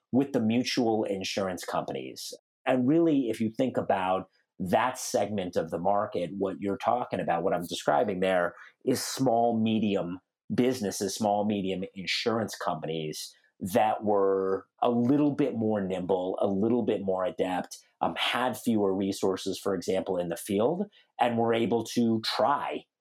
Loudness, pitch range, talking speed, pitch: -28 LUFS, 95-120 Hz, 150 wpm, 105 Hz